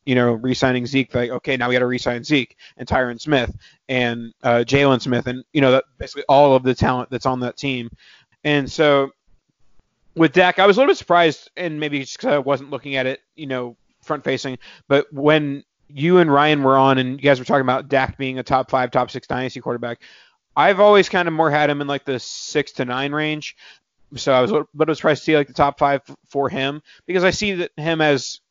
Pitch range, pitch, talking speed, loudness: 125-150 Hz, 135 Hz, 240 wpm, -19 LUFS